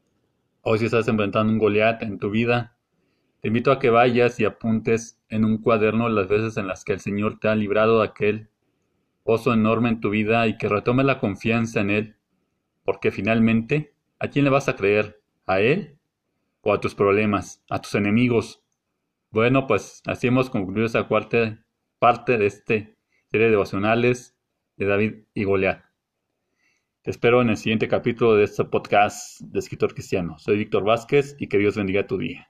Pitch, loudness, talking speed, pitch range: 110 Hz, -22 LUFS, 180 wpm, 105-115 Hz